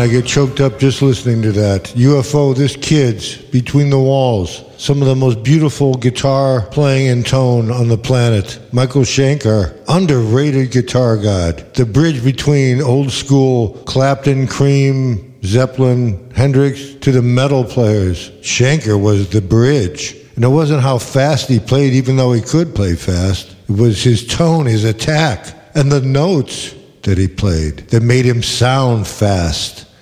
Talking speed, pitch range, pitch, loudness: 155 wpm, 110-135 Hz, 125 Hz, -13 LUFS